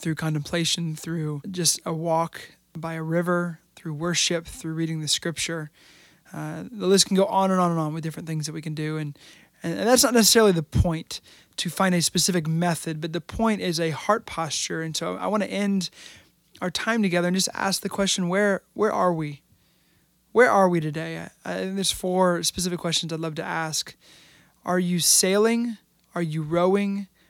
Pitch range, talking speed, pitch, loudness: 160-190 Hz, 195 wpm, 175 Hz, -24 LUFS